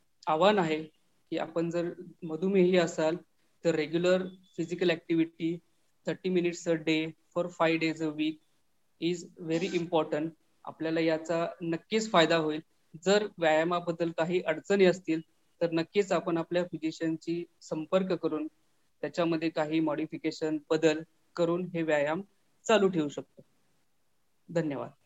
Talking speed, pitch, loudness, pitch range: 120 wpm, 165 Hz, -30 LUFS, 160-175 Hz